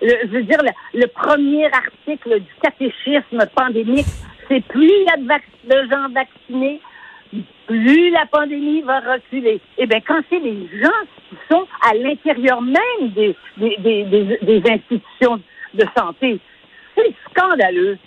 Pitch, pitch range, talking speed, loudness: 260 Hz, 225-300 Hz, 145 wpm, -16 LUFS